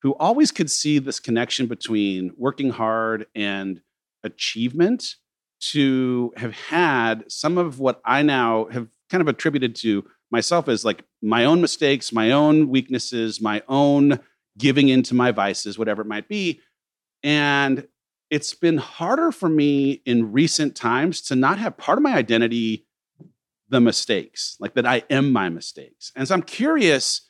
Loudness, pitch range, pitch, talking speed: -21 LUFS, 115-150 Hz, 130 Hz, 155 wpm